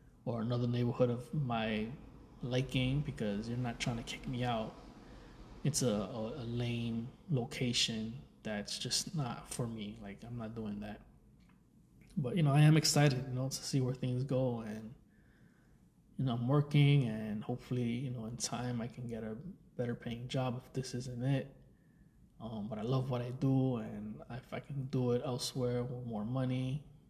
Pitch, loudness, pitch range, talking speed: 125 Hz, -36 LUFS, 115-130 Hz, 180 wpm